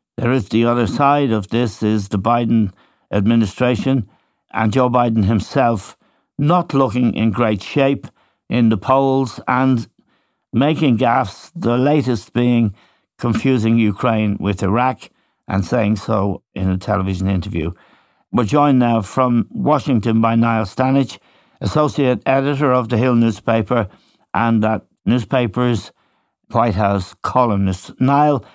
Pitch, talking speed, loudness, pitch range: 115 Hz, 130 wpm, -17 LUFS, 105-130 Hz